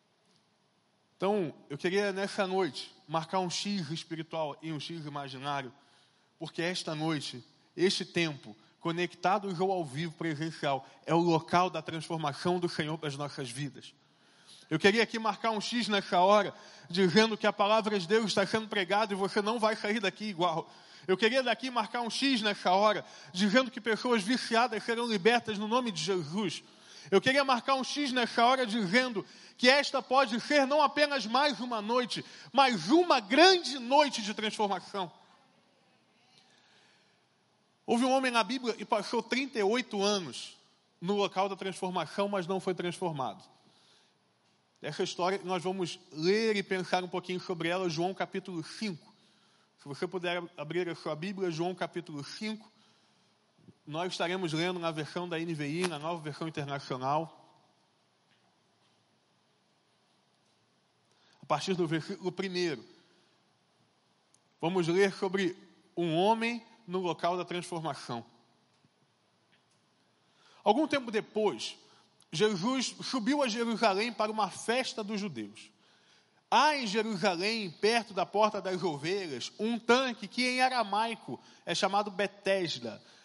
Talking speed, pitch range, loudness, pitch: 140 wpm, 170-225 Hz, -31 LUFS, 195 Hz